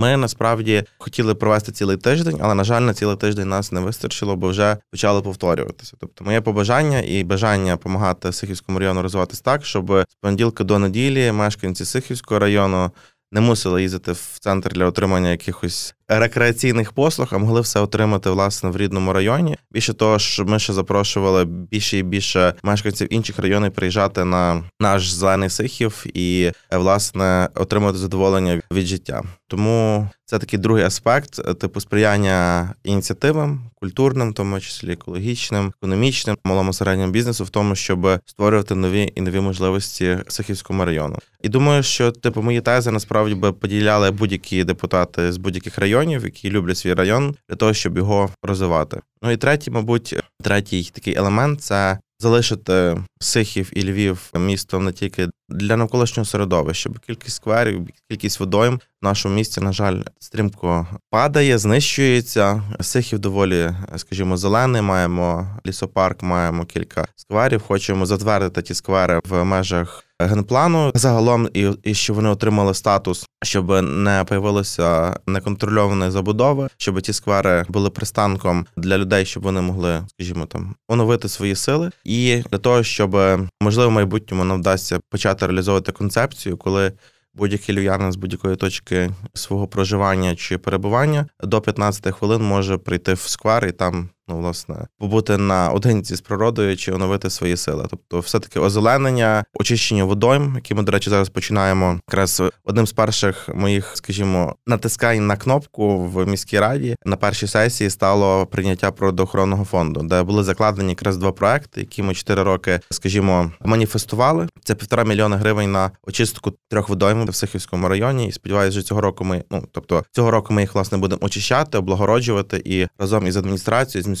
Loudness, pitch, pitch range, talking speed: -19 LUFS, 100 Hz, 95-110 Hz, 155 wpm